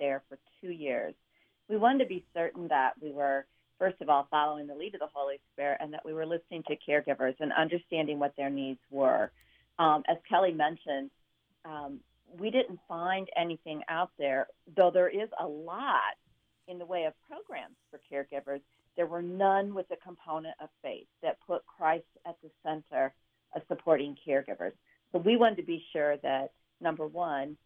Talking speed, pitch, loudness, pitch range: 180 wpm, 155 Hz, -32 LUFS, 140-175 Hz